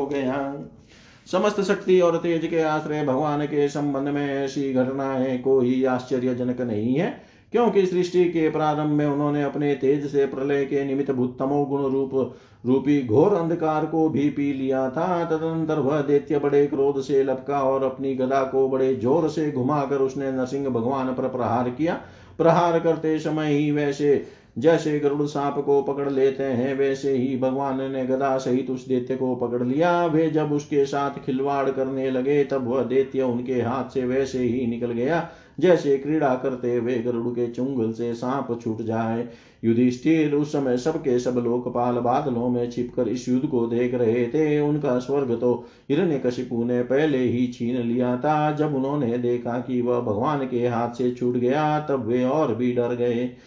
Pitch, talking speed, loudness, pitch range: 135 Hz, 175 wpm, -23 LUFS, 125-145 Hz